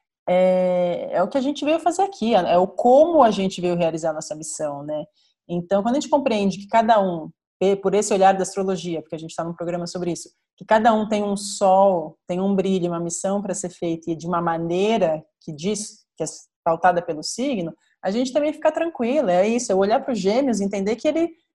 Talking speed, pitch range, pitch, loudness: 225 wpm, 175-230 Hz, 190 Hz, -21 LUFS